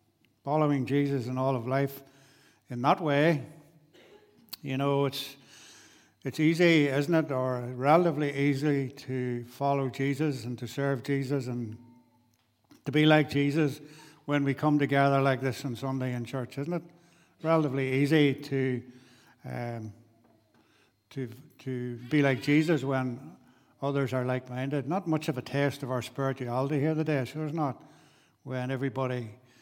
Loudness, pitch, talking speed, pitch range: -29 LUFS, 135 Hz, 140 wpm, 125-150 Hz